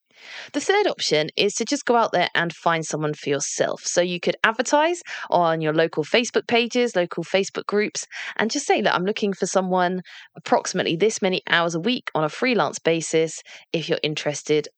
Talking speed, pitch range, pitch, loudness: 195 wpm, 165-230 Hz, 180 Hz, -22 LUFS